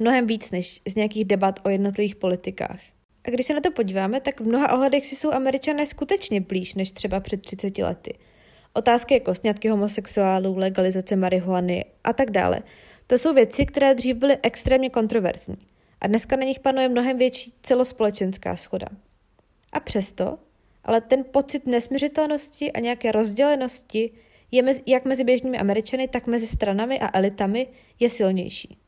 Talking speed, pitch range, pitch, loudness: 160 wpm, 200-260 Hz, 230 Hz, -23 LUFS